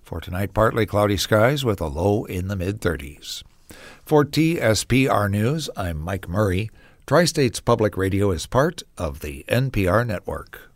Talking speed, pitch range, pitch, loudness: 155 wpm, 90-120 Hz, 105 Hz, -21 LUFS